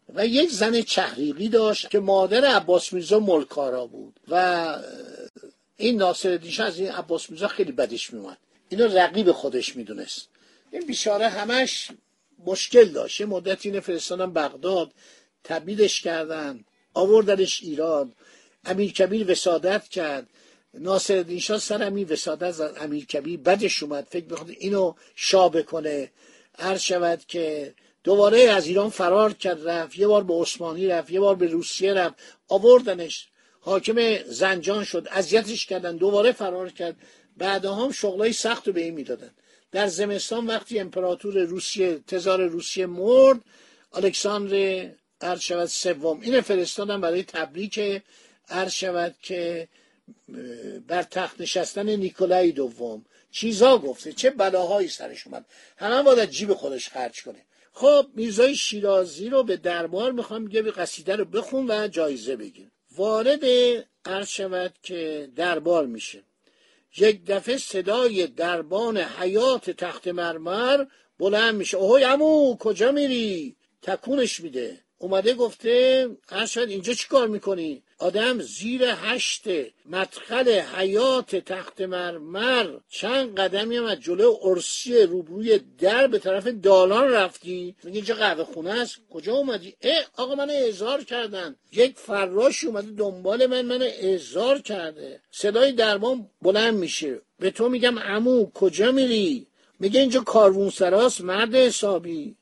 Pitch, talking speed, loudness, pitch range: 195 Hz, 135 wpm, -23 LUFS, 180-235 Hz